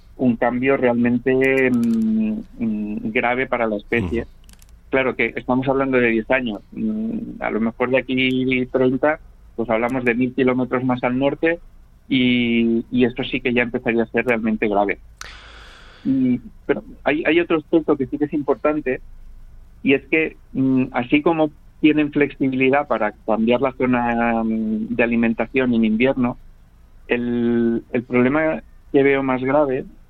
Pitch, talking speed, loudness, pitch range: 130 Hz, 150 wpm, -20 LUFS, 120-145 Hz